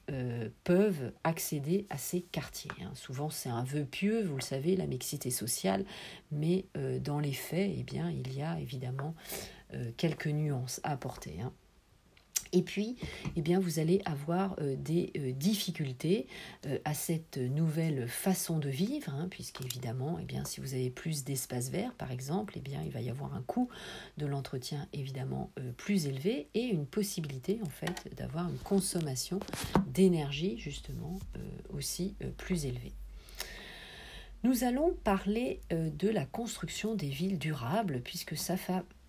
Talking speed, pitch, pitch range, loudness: 165 wpm, 160 Hz, 135-190 Hz, -35 LUFS